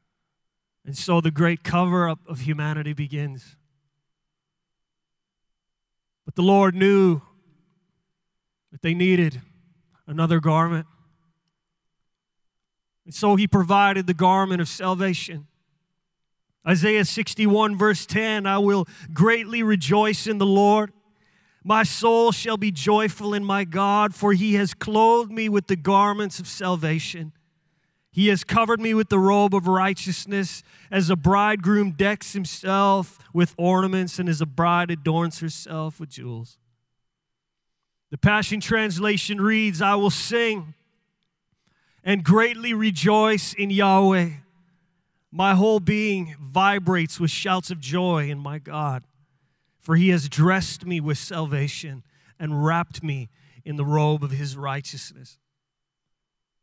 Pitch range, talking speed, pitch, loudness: 160-200 Hz, 125 wpm, 180 Hz, -21 LUFS